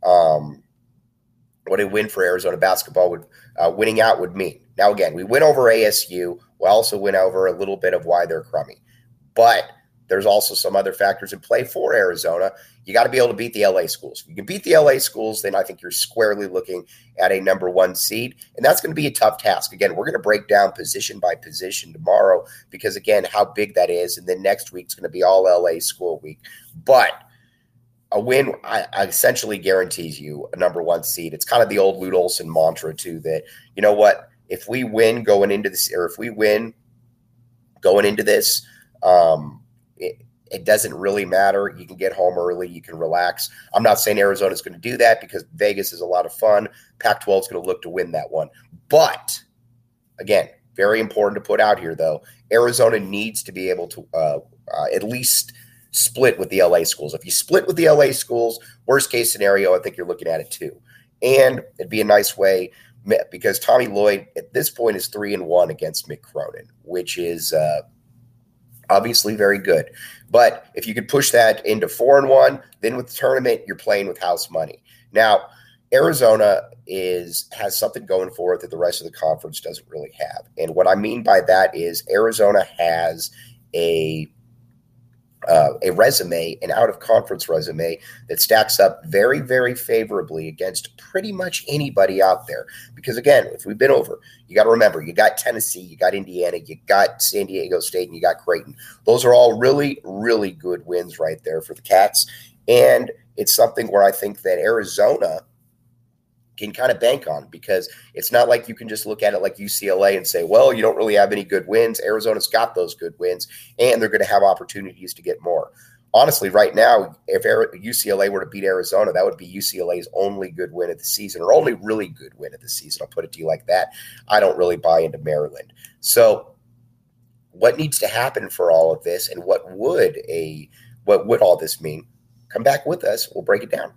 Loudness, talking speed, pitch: -18 LUFS, 205 wpm, 120 Hz